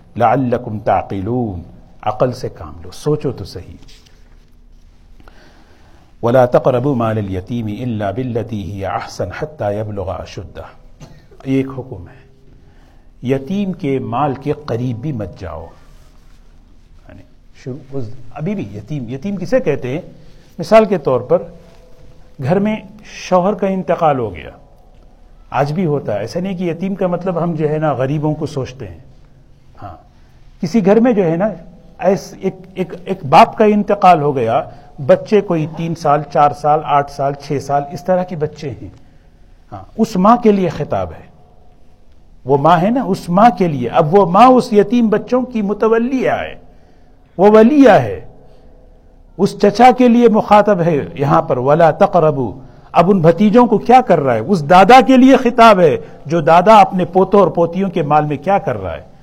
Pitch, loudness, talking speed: 150 Hz, -14 LUFS, 160 wpm